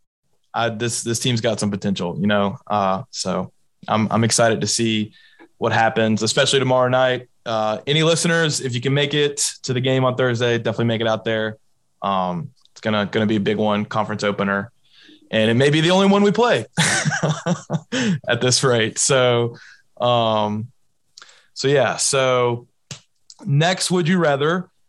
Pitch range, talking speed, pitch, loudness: 110-145 Hz, 170 wpm, 120 Hz, -19 LUFS